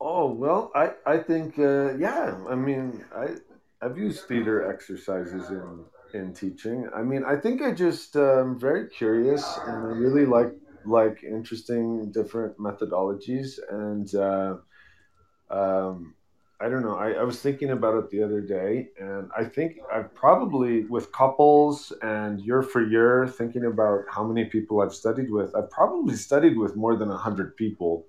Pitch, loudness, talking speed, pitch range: 115 Hz, -25 LUFS, 165 wpm, 100-130 Hz